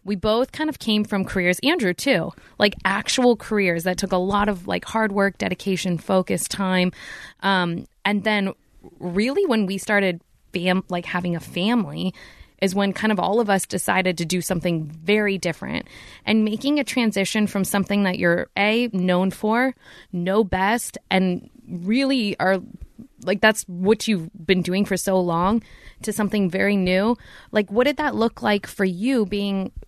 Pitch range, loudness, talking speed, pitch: 185-220 Hz, -22 LUFS, 175 wpm, 195 Hz